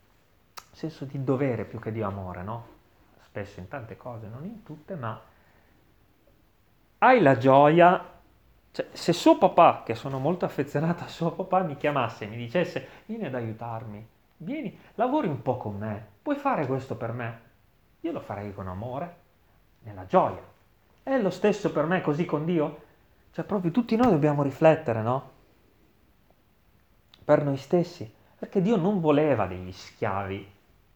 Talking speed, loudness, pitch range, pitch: 155 wpm, -26 LUFS, 110-170 Hz, 135 Hz